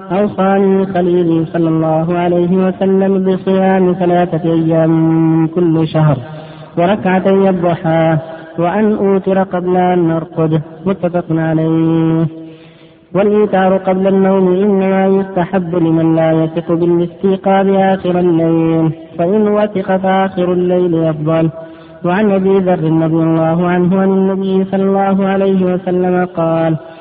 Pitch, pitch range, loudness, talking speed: 175 Hz, 165-190 Hz, -13 LUFS, 110 wpm